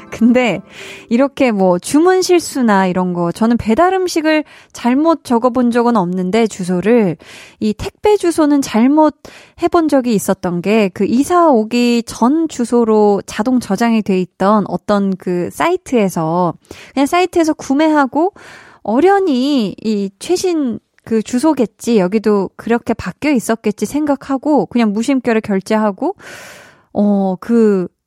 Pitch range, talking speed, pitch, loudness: 205-290 Hz, 270 characters per minute, 235 Hz, -14 LUFS